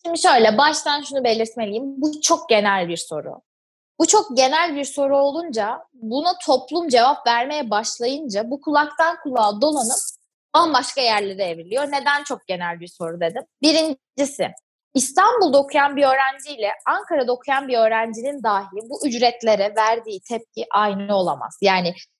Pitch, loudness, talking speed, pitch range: 265 Hz, -20 LUFS, 140 wpm, 220-295 Hz